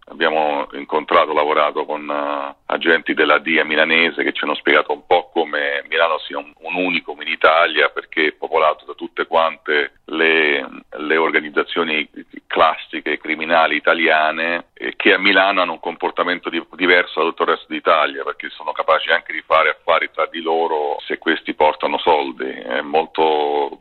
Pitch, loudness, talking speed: 80 Hz, -17 LUFS, 160 wpm